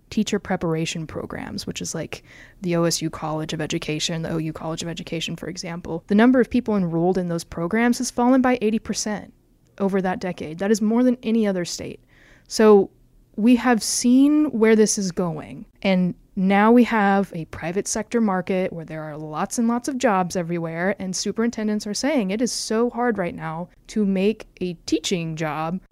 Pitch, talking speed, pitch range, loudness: 195 Hz, 185 wpm, 170-225 Hz, -22 LUFS